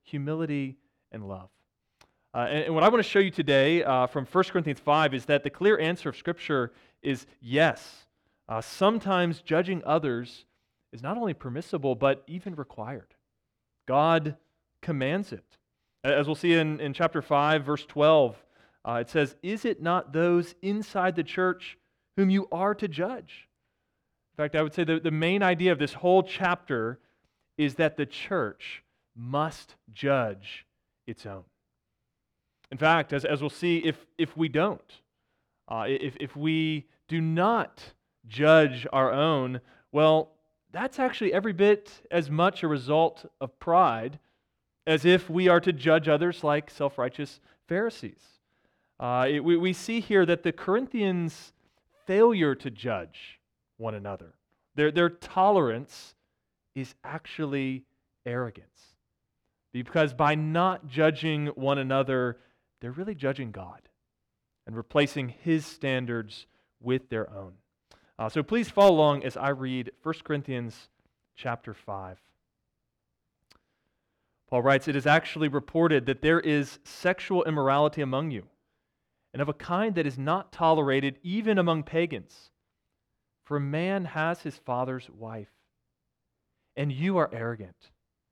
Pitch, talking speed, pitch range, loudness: 150 Hz, 145 wpm, 130-170 Hz, -27 LUFS